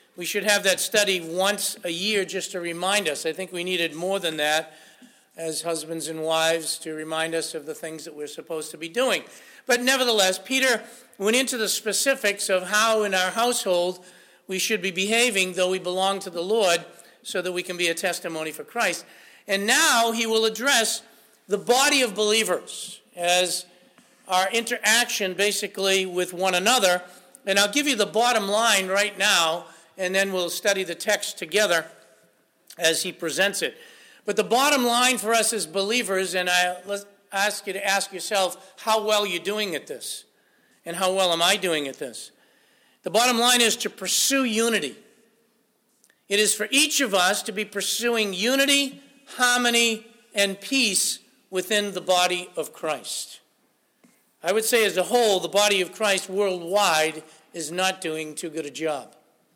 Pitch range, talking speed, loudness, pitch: 180-225 Hz, 175 wpm, -22 LUFS, 200 Hz